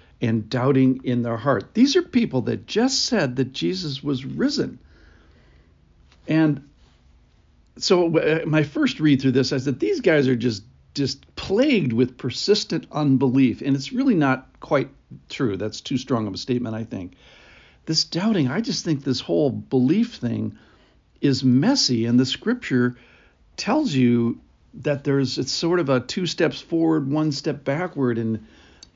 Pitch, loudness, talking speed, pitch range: 135 Hz, -22 LUFS, 155 wpm, 120-160 Hz